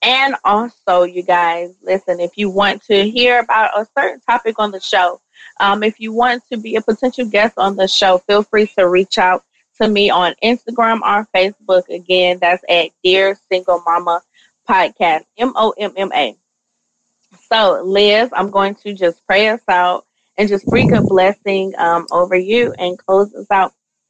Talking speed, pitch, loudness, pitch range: 180 wpm, 200 Hz, -14 LUFS, 185-220 Hz